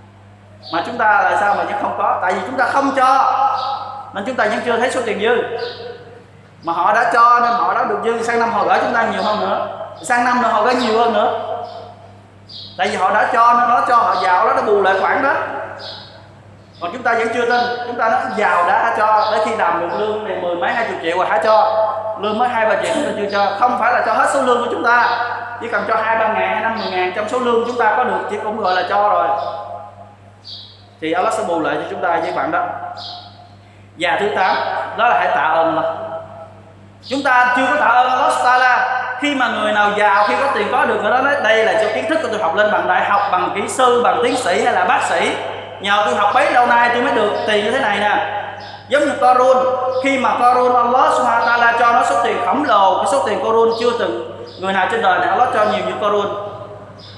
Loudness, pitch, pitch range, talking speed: -15 LUFS, 225 Hz, 195-245 Hz, 250 wpm